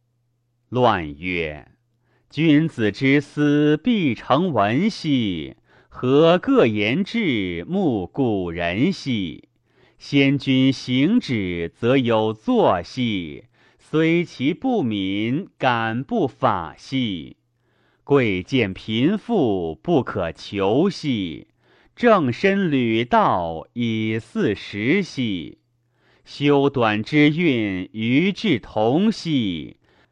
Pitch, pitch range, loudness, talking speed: 125 Hz, 110-145 Hz, -20 LUFS, 115 characters per minute